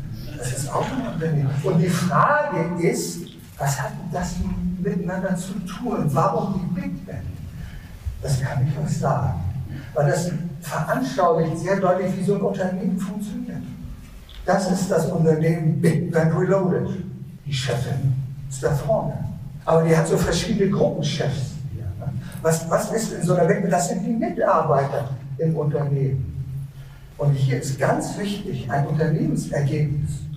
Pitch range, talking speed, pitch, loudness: 140-185 Hz, 140 wpm, 160 Hz, -23 LUFS